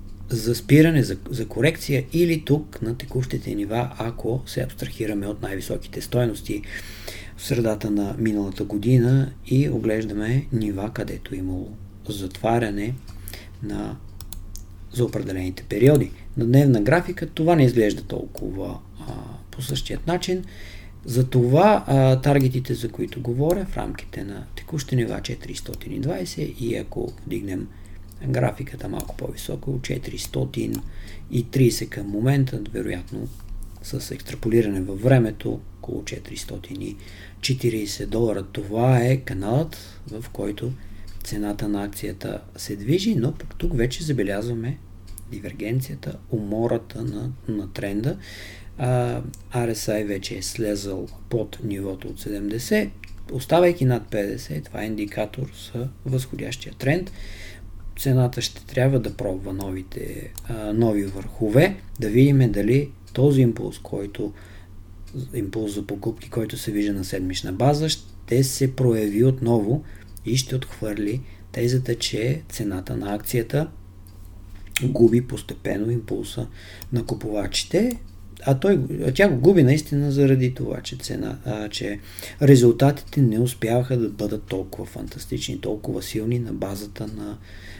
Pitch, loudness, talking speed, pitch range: 110 Hz, -23 LUFS, 120 wpm, 100-130 Hz